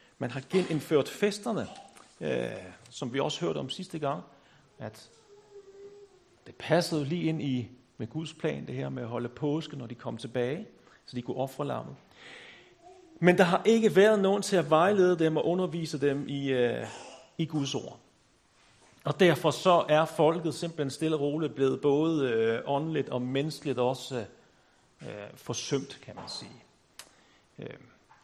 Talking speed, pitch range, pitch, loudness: 150 wpm, 135-175 Hz, 155 Hz, -29 LUFS